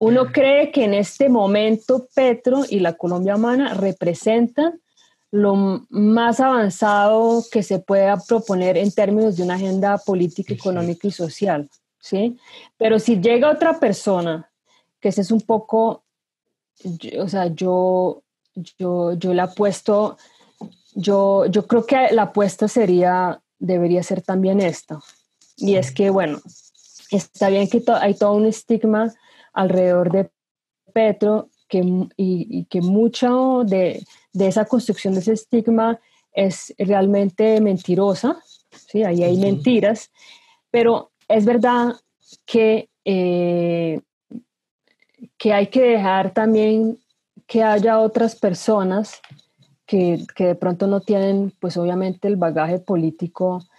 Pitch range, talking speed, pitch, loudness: 185-225 Hz, 130 wpm, 205 Hz, -19 LUFS